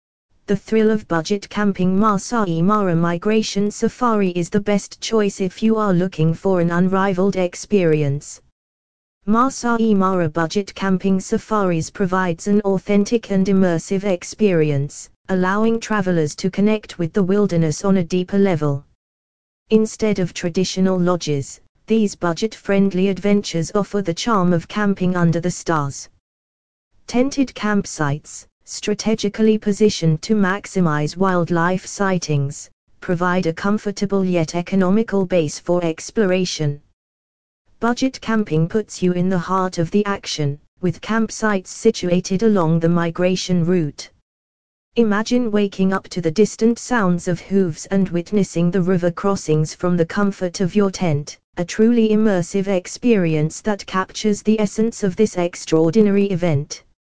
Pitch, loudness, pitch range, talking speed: 185 Hz, -19 LUFS, 165-205 Hz, 130 wpm